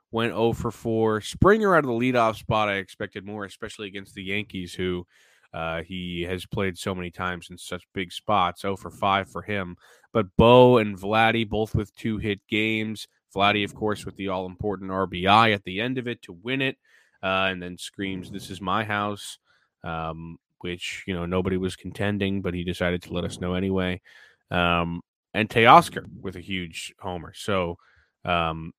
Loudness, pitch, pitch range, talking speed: -24 LUFS, 95 Hz, 90-105 Hz, 190 wpm